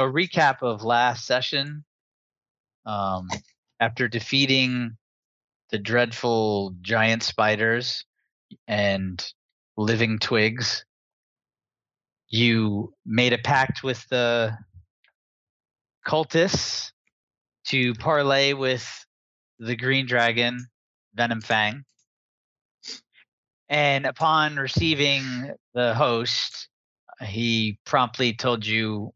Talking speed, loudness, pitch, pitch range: 80 wpm, -23 LUFS, 120 Hz, 110-130 Hz